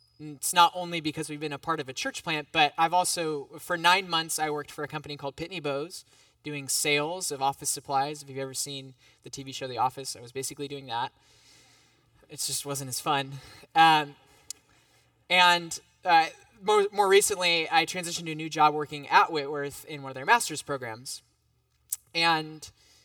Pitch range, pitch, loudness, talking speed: 140-165 Hz, 150 Hz, -27 LUFS, 190 wpm